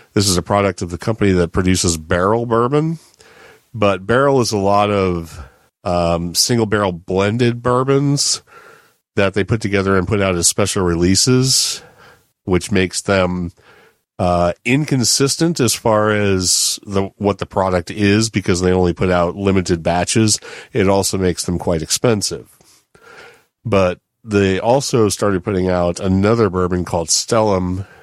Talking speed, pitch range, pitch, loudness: 145 wpm, 90-110 Hz, 95 Hz, -16 LUFS